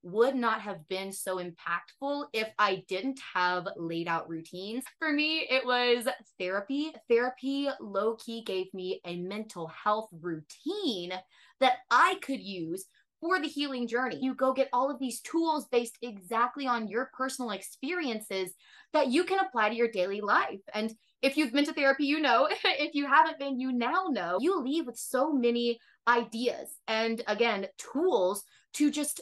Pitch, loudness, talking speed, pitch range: 240 Hz, -30 LUFS, 170 wpm, 200-280 Hz